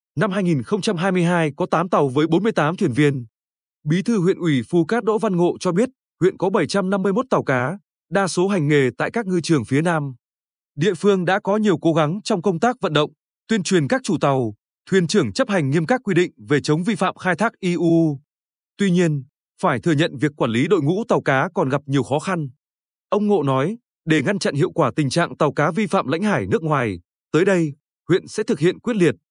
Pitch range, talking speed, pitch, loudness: 150-200 Hz, 225 wpm, 175 Hz, -20 LUFS